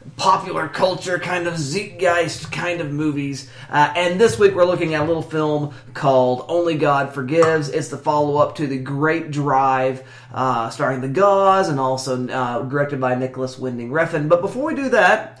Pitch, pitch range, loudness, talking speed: 150 Hz, 130-175 Hz, -19 LUFS, 180 wpm